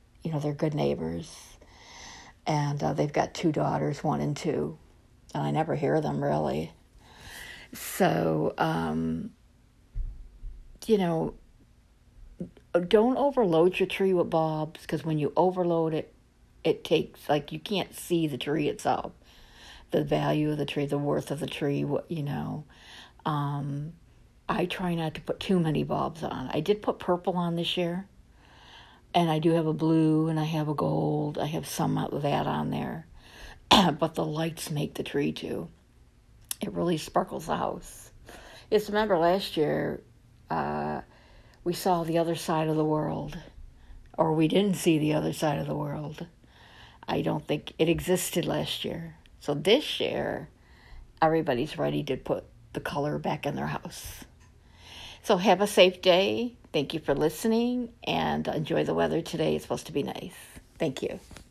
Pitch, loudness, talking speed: 155 Hz, -28 LUFS, 165 wpm